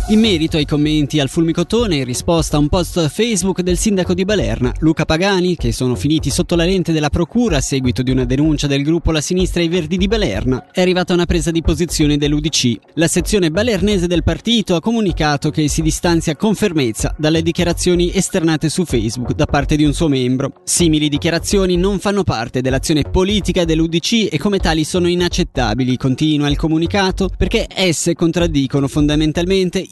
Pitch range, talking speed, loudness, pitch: 150-185 Hz, 185 wpm, -16 LUFS, 165 Hz